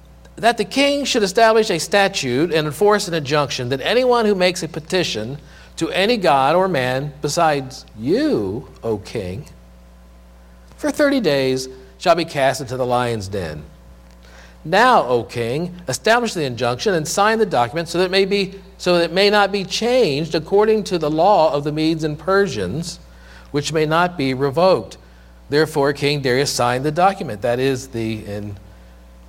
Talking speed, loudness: 170 wpm, -18 LUFS